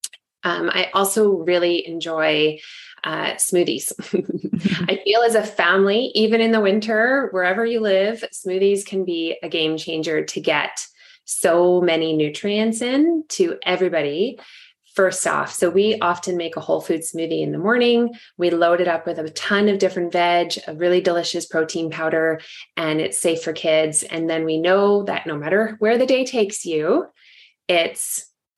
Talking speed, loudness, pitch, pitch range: 165 wpm, -20 LUFS, 180 Hz, 165-215 Hz